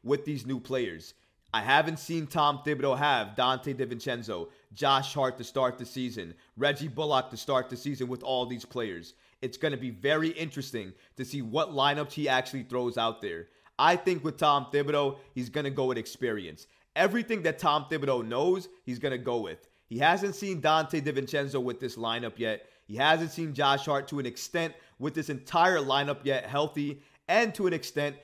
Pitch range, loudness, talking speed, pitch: 125-155 Hz, -29 LUFS, 185 wpm, 140 Hz